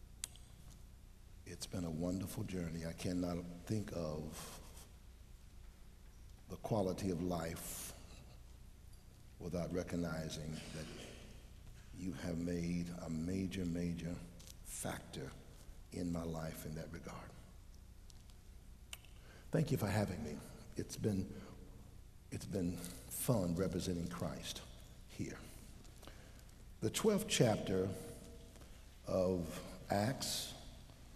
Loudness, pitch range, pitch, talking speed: -42 LUFS, 80-95 Hz, 90 Hz, 90 wpm